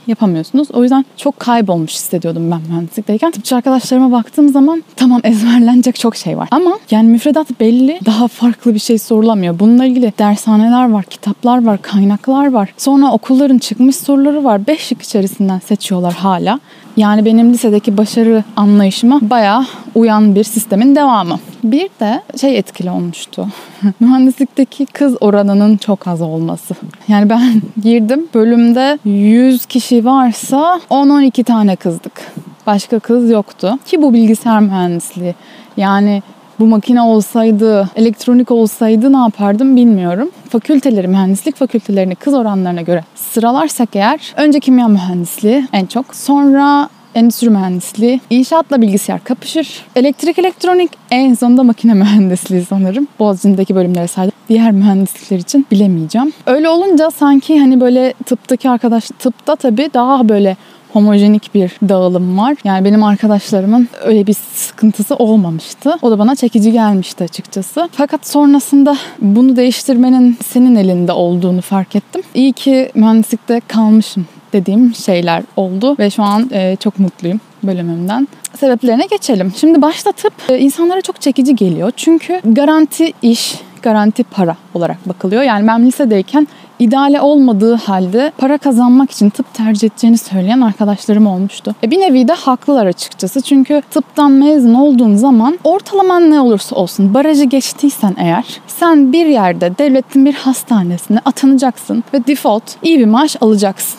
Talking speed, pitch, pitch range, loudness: 135 wpm, 230 Hz, 205-270 Hz, -11 LUFS